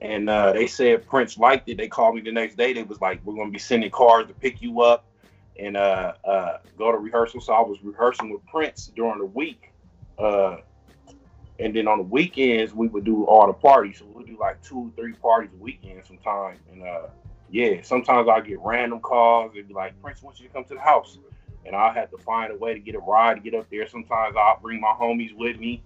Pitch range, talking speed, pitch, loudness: 100-120 Hz, 245 wpm, 115 Hz, -21 LUFS